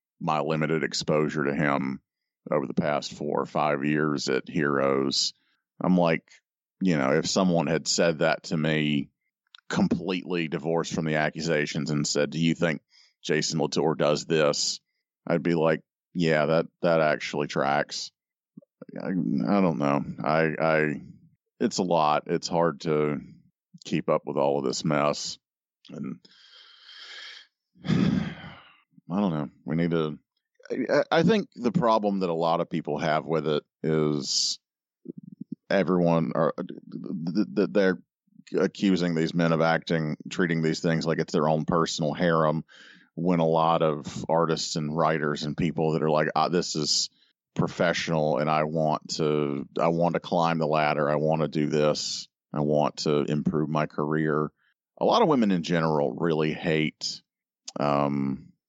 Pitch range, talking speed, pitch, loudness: 75-85 Hz, 155 wpm, 80 Hz, -26 LUFS